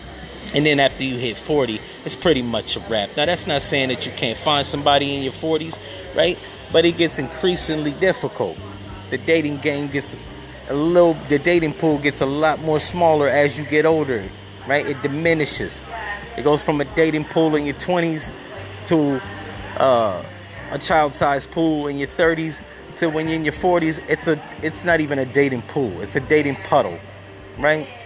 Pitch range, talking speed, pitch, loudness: 135-160 Hz, 185 wpm, 145 Hz, -20 LUFS